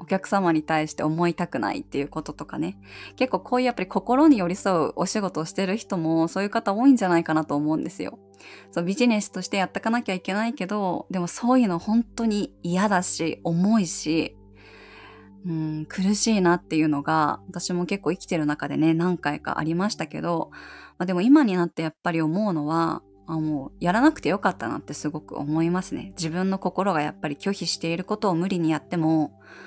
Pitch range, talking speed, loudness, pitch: 155-195 Hz, 410 characters per minute, -24 LUFS, 175 Hz